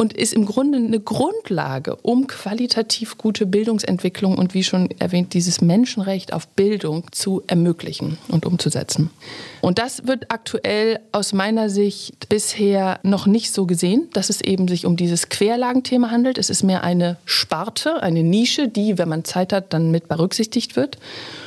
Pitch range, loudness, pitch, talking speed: 180-225 Hz, -19 LUFS, 200 Hz, 160 wpm